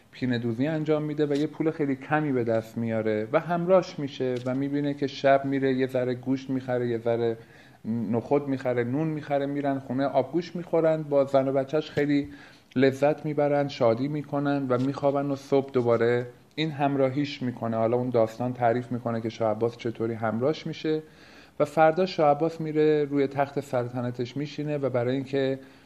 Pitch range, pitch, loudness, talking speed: 125-150 Hz, 135 Hz, -26 LUFS, 170 wpm